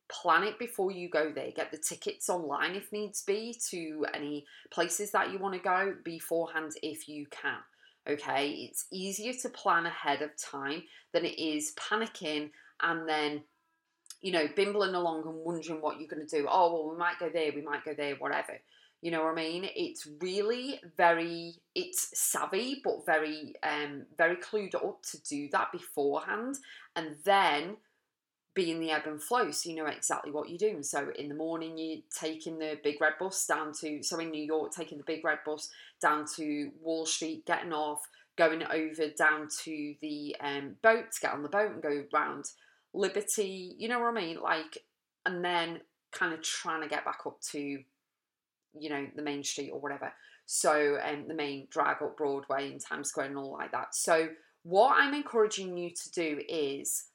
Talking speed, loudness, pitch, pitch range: 195 wpm, -33 LUFS, 160 Hz, 150-190 Hz